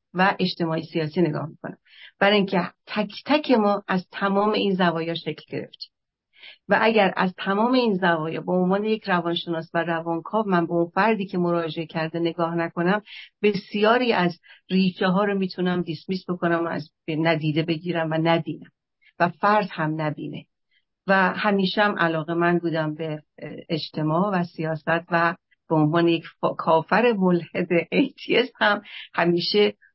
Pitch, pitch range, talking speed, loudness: 175 Hz, 165-200 Hz, 150 wpm, -23 LUFS